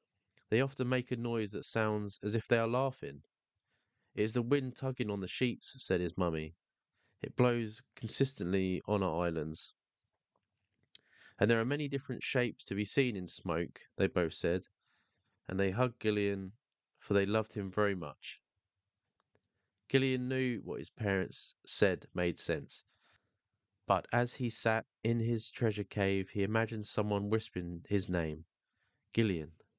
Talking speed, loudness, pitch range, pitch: 155 wpm, -35 LUFS, 95-120 Hz, 105 Hz